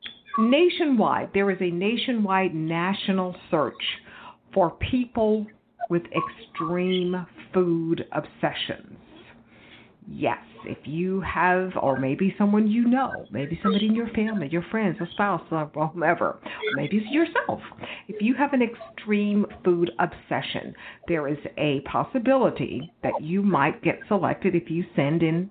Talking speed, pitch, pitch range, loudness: 135 wpm, 190 Hz, 170-220 Hz, -25 LUFS